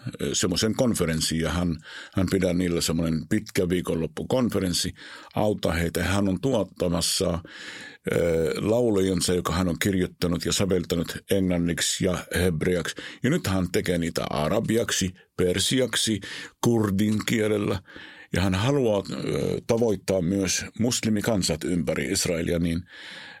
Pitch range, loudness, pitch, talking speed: 85-105 Hz, -25 LUFS, 95 Hz, 115 wpm